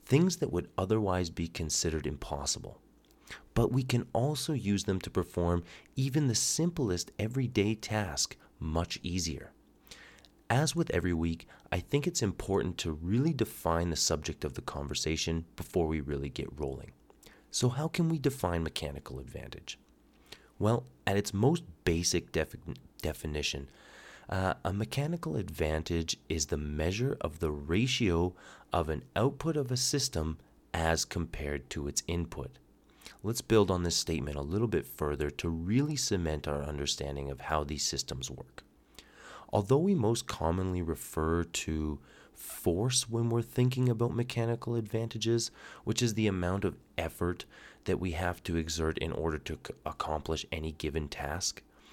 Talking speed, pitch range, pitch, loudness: 150 wpm, 80-115 Hz, 90 Hz, -32 LUFS